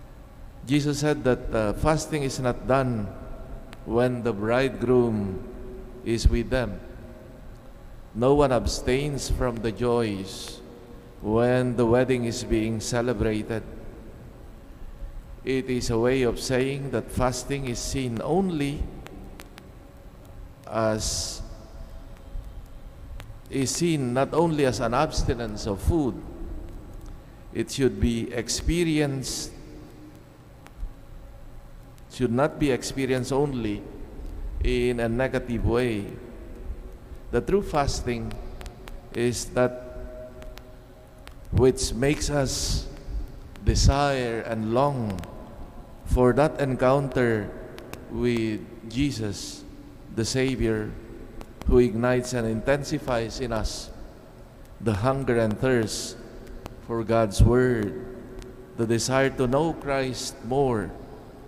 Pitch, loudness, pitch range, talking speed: 125 Hz, -25 LUFS, 110-130 Hz, 95 wpm